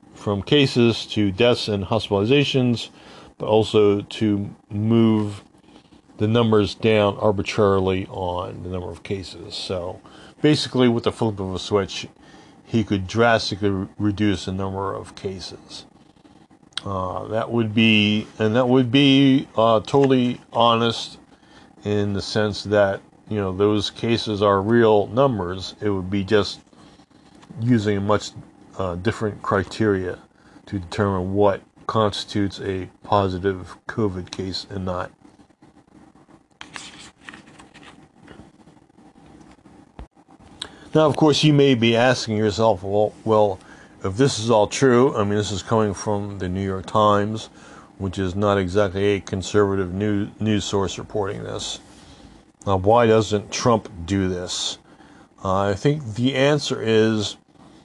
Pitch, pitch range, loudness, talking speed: 105 Hz, 100-115 Hz, -21 LUFS, 130 wpm